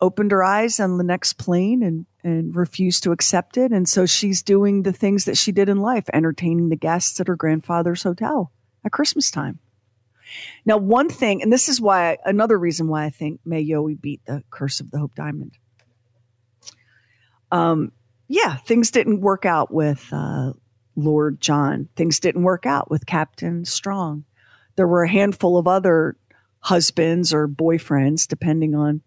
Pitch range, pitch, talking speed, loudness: 145-195 Hz, 165 Hz, 170 wpm, -19 LUFS